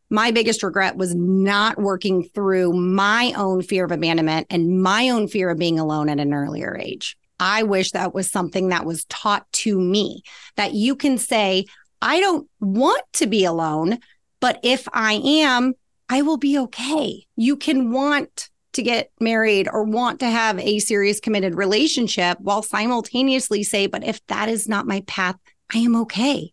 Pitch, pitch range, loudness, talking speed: 210 Hz, 185-245 Hz, -20 LUFS, 175 wpm